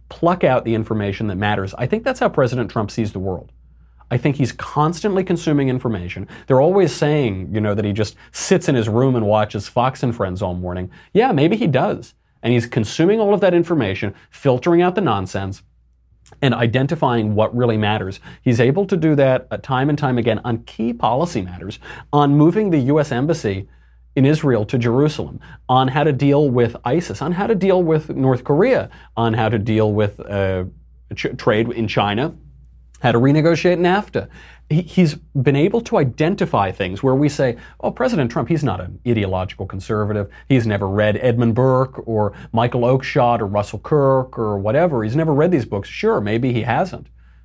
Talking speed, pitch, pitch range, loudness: 190 wpm, 120 Hz, 105-150 Hz, -18 LUFS